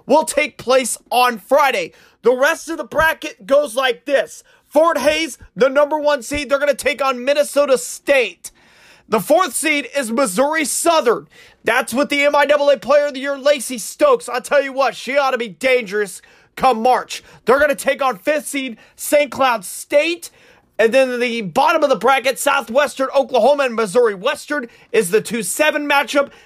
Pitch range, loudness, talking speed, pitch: 250-295 Hz, -17 LUFS, 175 wpm, 280 Hz